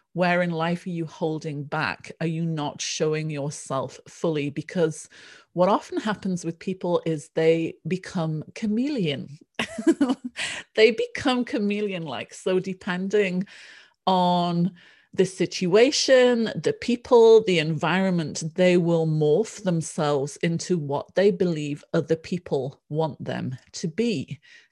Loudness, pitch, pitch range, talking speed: -24 LUFS, 175 Hz, 160-205 Hz, 120 wpm